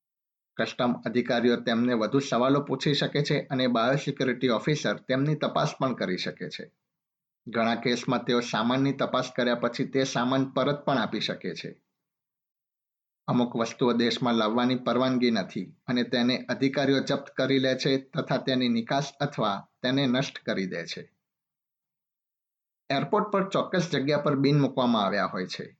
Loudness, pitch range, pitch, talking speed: -27 LUFS, 120-140 Hz, 130 Hz, 145 wpm